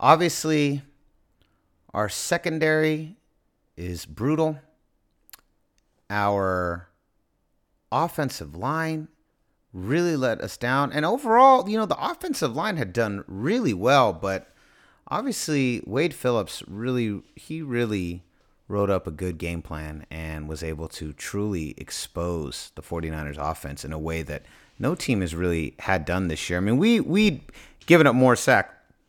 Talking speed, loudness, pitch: 135 wpm, -24 LUFS, 110 Hz